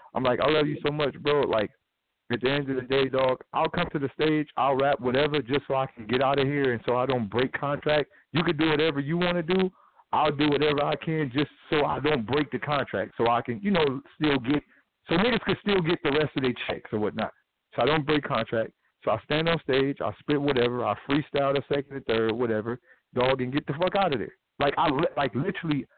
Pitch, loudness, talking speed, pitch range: 145 Hz, -26 LUFS, 250 wpm, 130-155 Hz